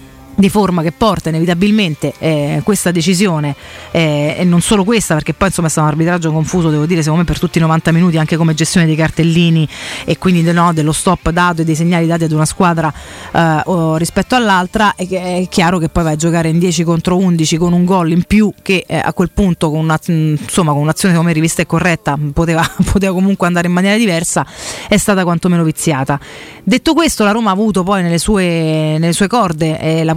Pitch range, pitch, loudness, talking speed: 160-185 Hz, 170 Hz, -13 LUFS, 210 wpm